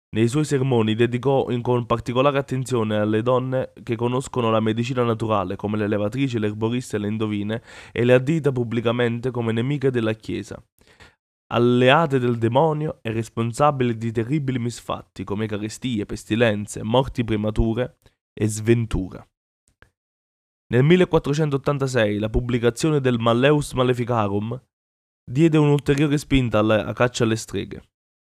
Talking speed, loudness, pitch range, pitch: 125 wpm, -22 LUFS, 110-130 Hz, 120 Hz